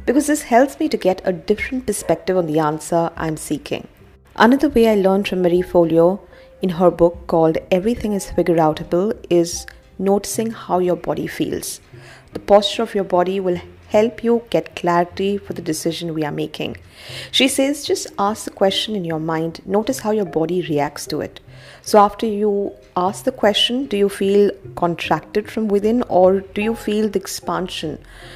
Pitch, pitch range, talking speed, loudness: 195 Hz, 170-215 Hz, 180 wpm, -19 LUFS